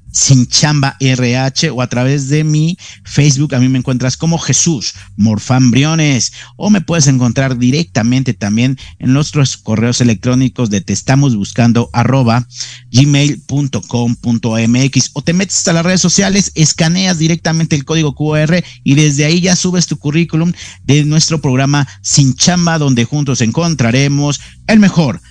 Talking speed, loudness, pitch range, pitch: 145 wpm, -12 LUFS, 125-160 Hz, 135 Hz